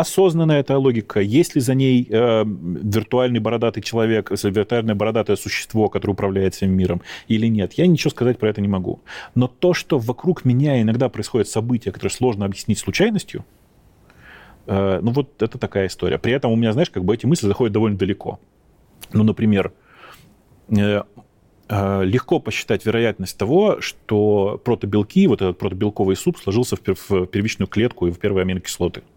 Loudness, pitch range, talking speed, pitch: -19 LUFS, 100-125 Hz, 165 wpm, 110 Hz